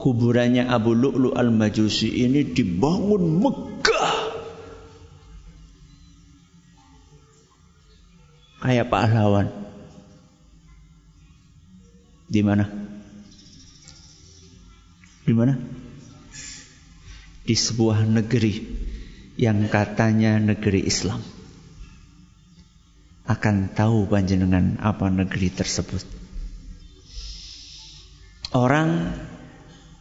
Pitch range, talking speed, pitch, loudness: 90-115 Hz, 60 wpm, 100 Hz, -21 LUFS